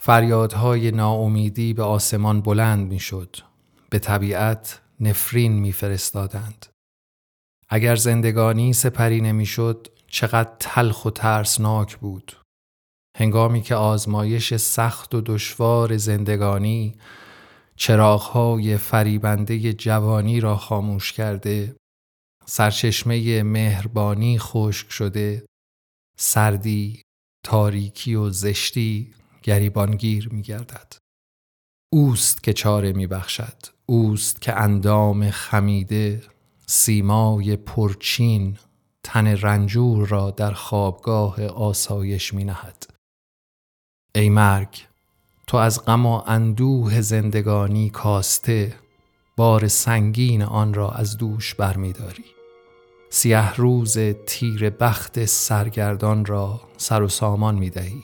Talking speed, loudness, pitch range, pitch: 95 wpm, -20 LUFS, 100-115 Hz, 105 Hz